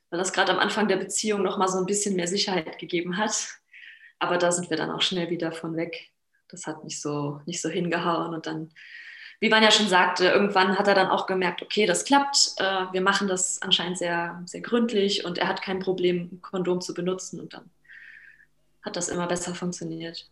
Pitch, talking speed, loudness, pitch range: 180 Hz, 215 wpm, -24 LUFS, 175-195 Hz